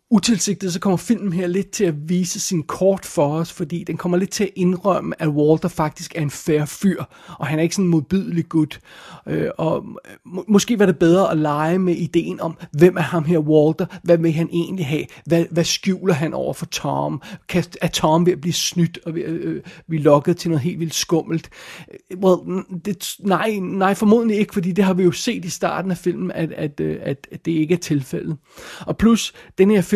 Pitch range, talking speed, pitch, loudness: 165-190 Hz, 225 wpm, 175 Hz, -20 LUFS